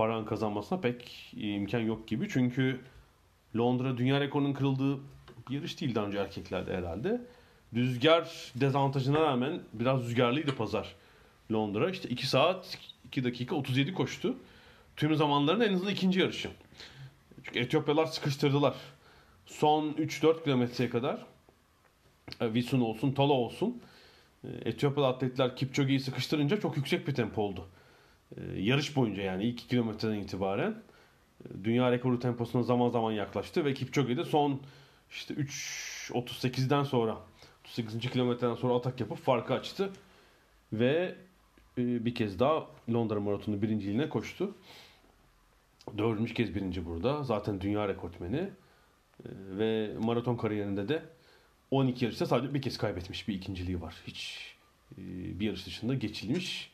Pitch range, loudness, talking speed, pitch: 110-140 Hz, -32 LUFS, 125 wpm, 125 Hz